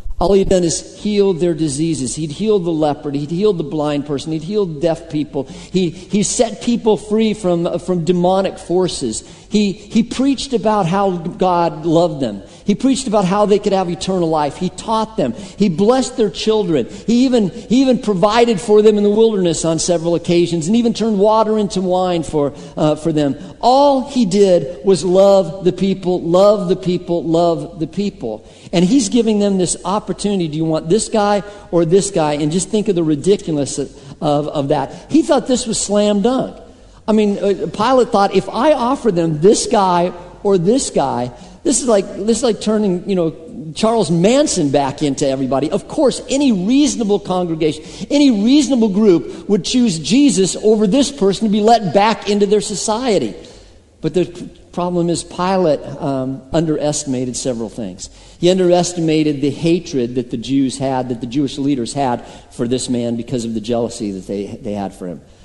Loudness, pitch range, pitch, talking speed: -16 LUFS, 155-215 Hz, 185 Hz, 185 wpm